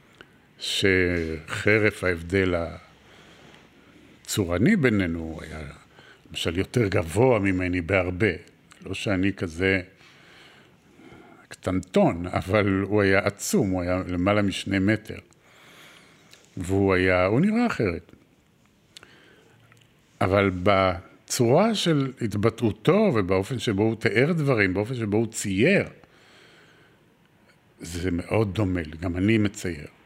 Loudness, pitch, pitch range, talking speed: -24 LUFS, 95 Hz, 90-110 Hz, 100 wpm